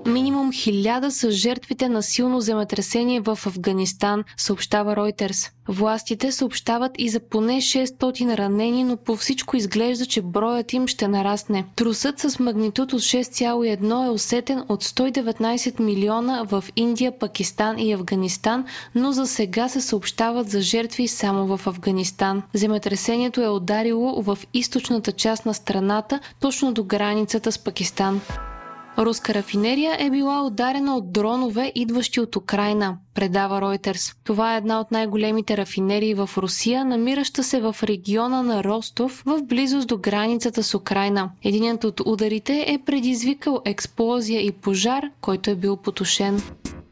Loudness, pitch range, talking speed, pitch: -22 LUFS, 205-250 Hz, 140 wpm, 225 Hz